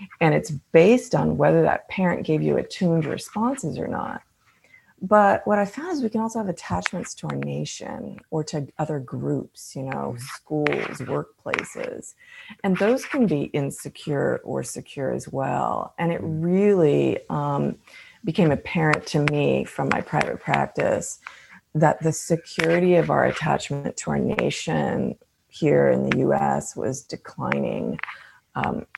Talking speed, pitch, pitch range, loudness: 145 wpm, 165 Hz, 150-205 Hz, -23 LUFS